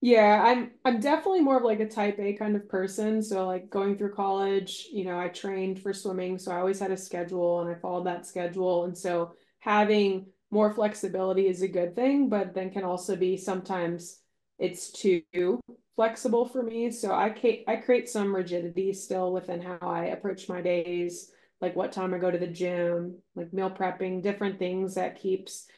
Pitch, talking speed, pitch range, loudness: 190 Hz, 195 wpm, 180-210 Hz, -28 LUFS